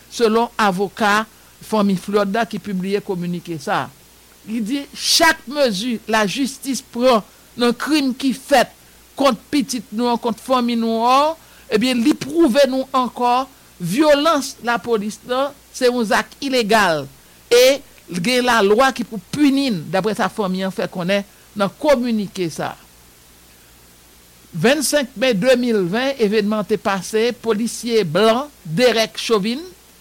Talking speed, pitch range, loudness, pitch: 130 wpm, 200-260 Hz, -18 LUFS, 230 Hz